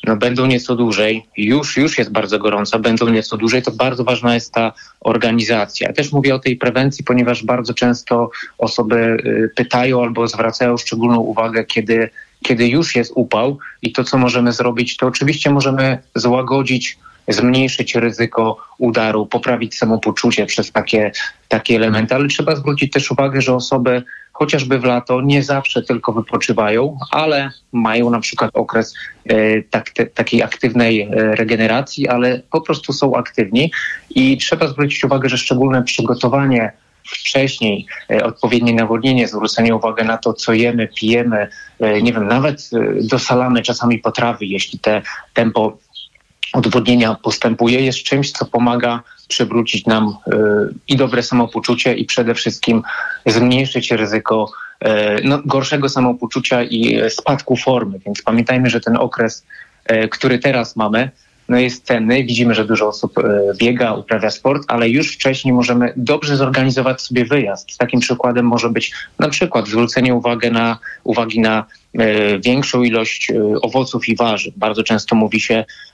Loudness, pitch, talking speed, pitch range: -15 LUFS, 120 Hz, 145 wpm, 115-130 Hz